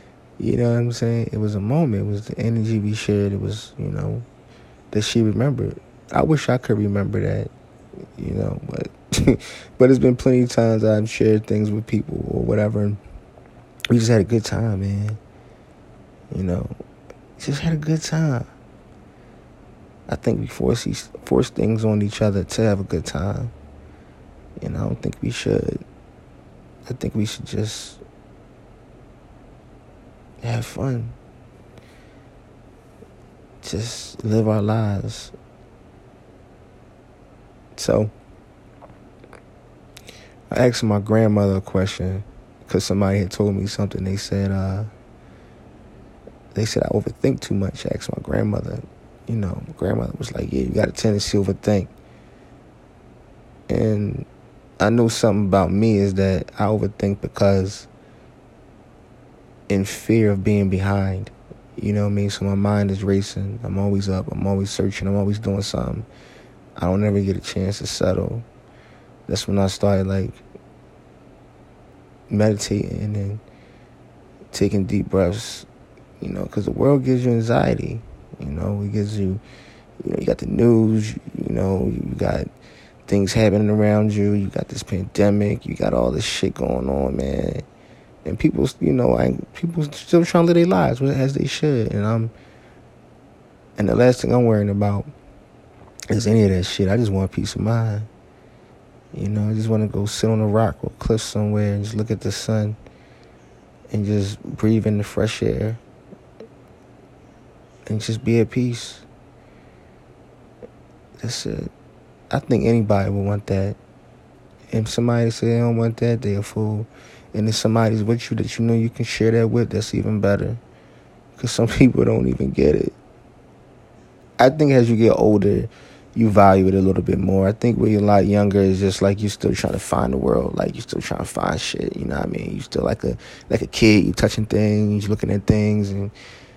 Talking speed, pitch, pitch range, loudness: 170 wpm, 105 Hz, 100-115 Hz, -21 LUFS